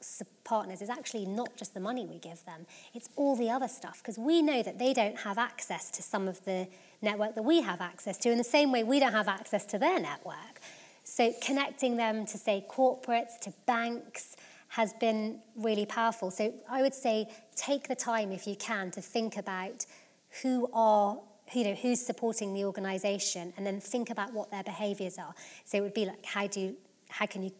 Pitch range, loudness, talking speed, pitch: 200-240 Hz, -32 LUFS, 210 wpm, 220 Hz